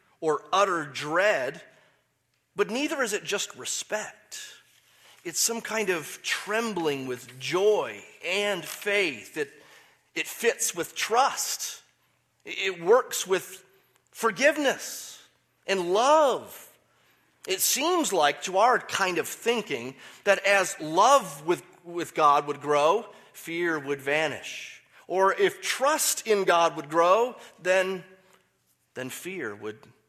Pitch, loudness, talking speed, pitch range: 195 Hz, -26 LUFS, 120 wpm, 165-265 Hz